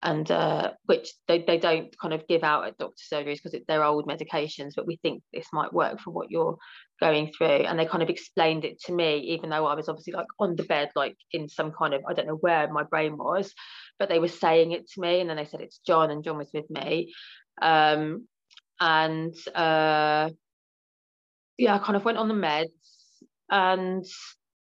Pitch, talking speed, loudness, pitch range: 160 Hz, 215 wpm, -26 LUFS, 155-175 Hz